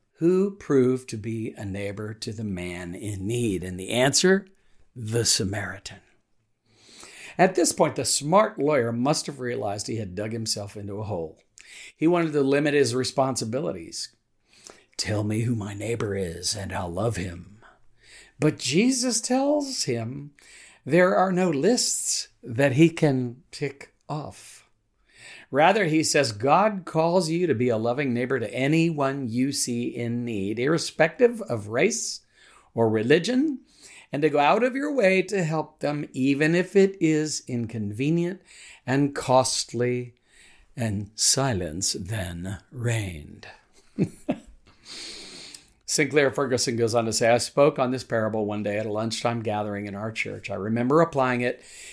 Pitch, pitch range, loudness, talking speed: 125 Hz, 110-155 Hz, -24 LUFS, 150 wpm